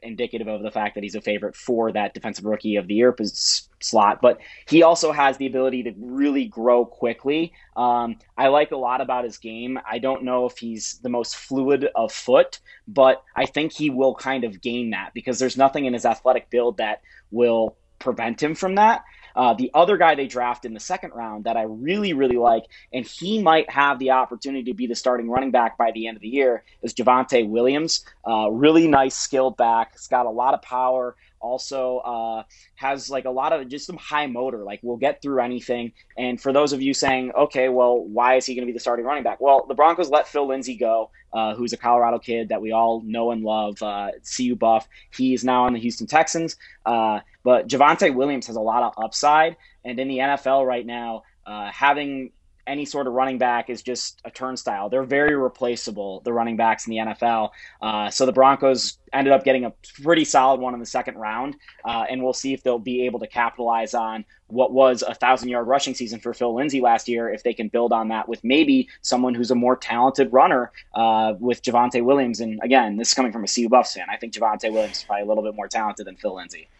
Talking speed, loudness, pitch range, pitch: 225 wpm, -21 LUFS, 115-135 Hz, 125 Hz